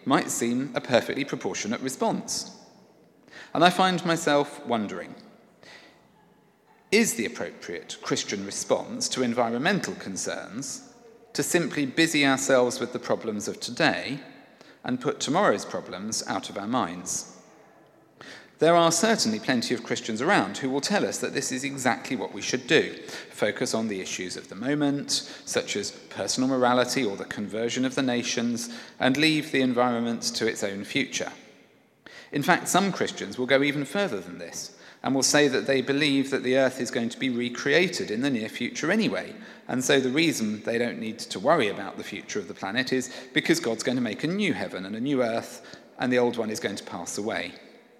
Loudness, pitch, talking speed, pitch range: -26 LUFS, 135 Hz, 185 wpm, 125-165 Hz